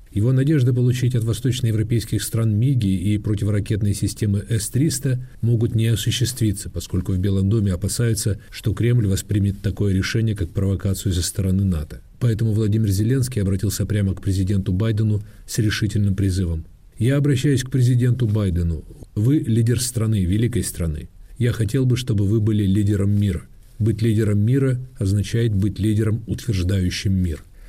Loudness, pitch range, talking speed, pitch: -21 LUFS, 95-115 Hz, 145 wpm, 105 Hz